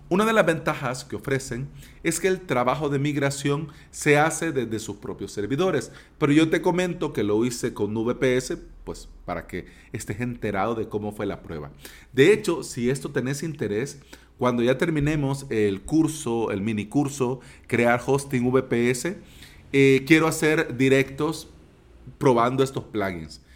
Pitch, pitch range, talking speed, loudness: 130 Hz, 110-150 Hz, 155 wpm, -24 LUFS